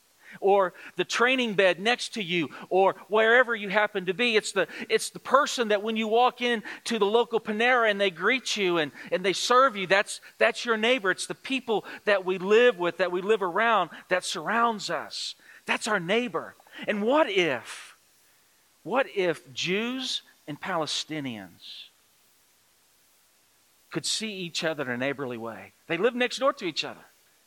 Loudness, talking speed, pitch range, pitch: -26 LUFS, 175 wpm, 180-240 Hz, 210 Hz